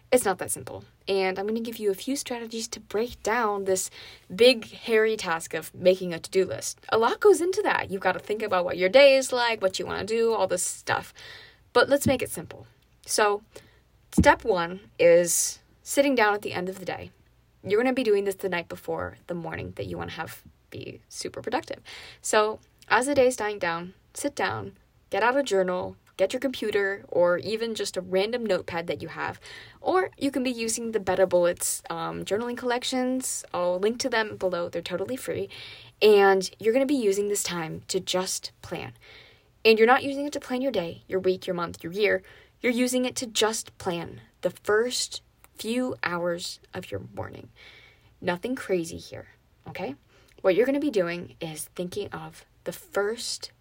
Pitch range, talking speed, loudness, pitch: 180-245 Hz, 205 wpm, -26 LUFS, 200 Hz